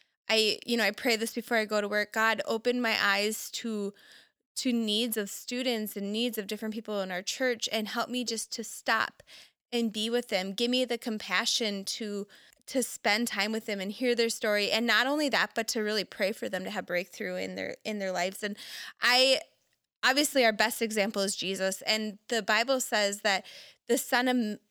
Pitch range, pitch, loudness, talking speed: 205-240 Hz, 220 Hz, -29 LUFS, 210 wpm